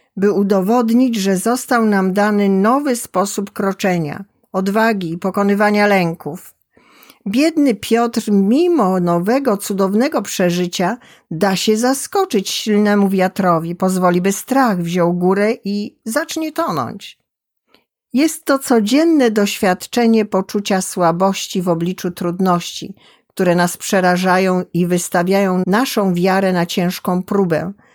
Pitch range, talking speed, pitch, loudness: 185-230 Hz, 110 wpm, 200 Hz, -16 LUFS